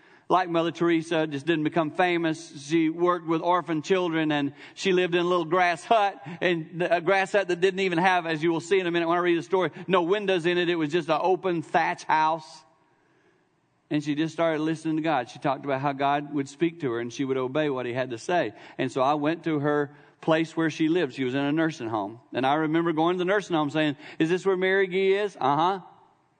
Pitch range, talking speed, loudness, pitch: 155-180 Hz, 250 wpm, -25 LUFS, 165 Hz